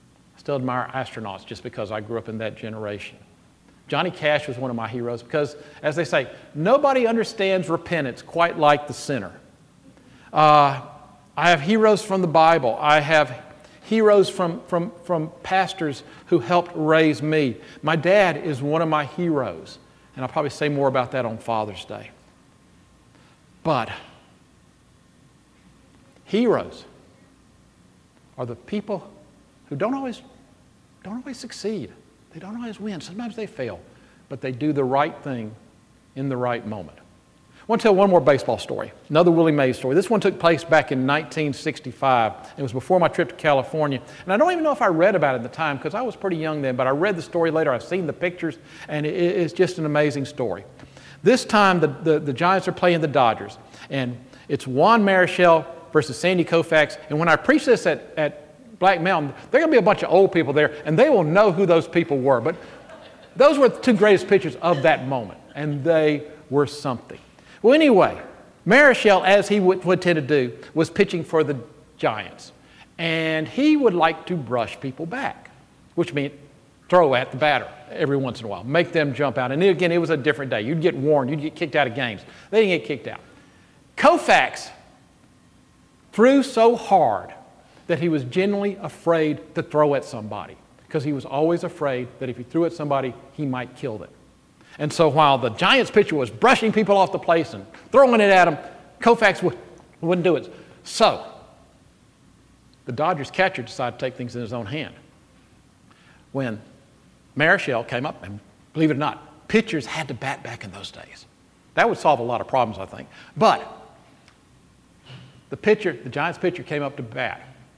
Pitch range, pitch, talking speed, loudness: 135-180 Hz, 155 Hz, 190 wpm, -21 LUFS